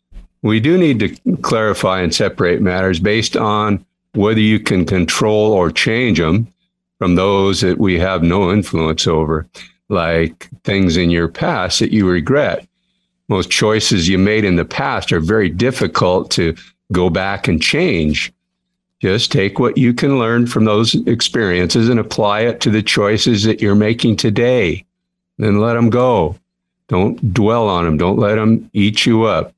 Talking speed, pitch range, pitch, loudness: 165 wpm, 90-115 Hz, 105 Hz, -14 LUFS